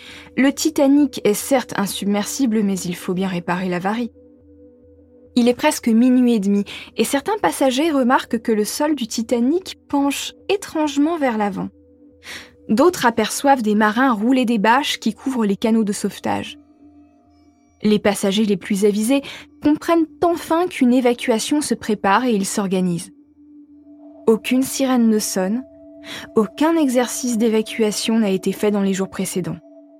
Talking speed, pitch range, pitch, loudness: 140 wpm, 205-290 Hz, 240 Hz, -19 LUFS